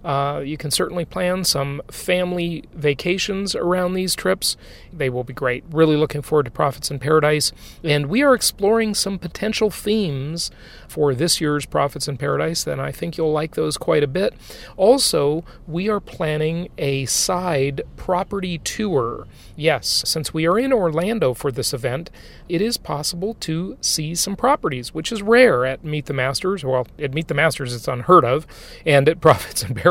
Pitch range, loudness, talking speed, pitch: 145-185 Hz, -20 LUFS, 175 wpm, 160 Hz